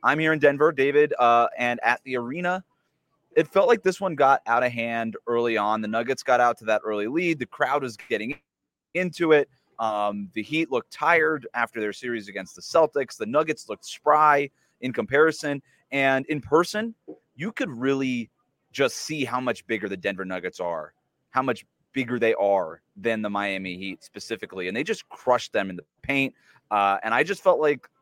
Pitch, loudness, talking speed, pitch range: 130 Hz, -24 LUFS, 195 wpm, 110-150 Hz